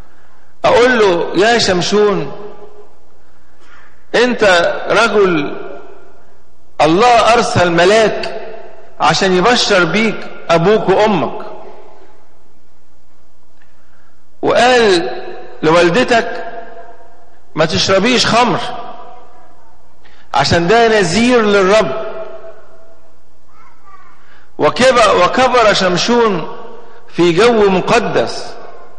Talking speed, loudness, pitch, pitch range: 60 wpm, -11 LUFS, 210 Hz, 170-230 Hz